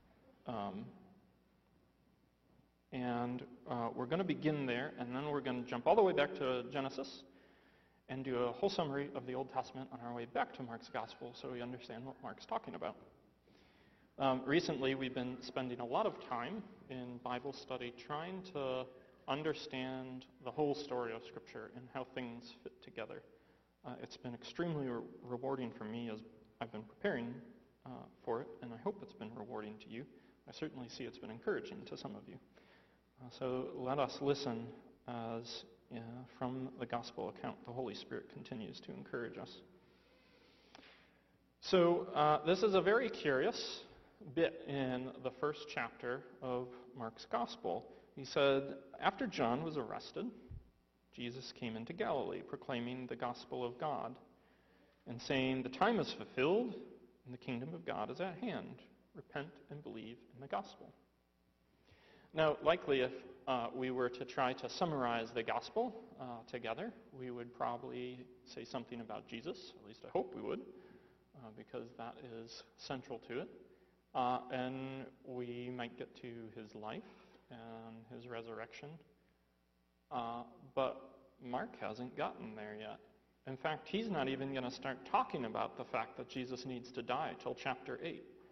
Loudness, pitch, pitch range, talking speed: -41 LUFS, 125 Hz, 120-135 Hz, 165 wpm